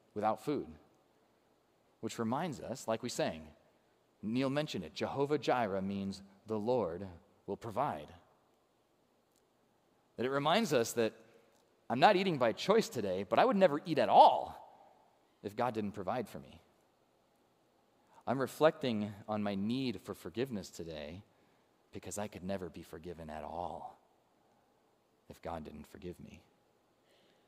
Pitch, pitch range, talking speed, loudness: 110 Hz, 95-120 Hz, 140 wpm, -34 LUFS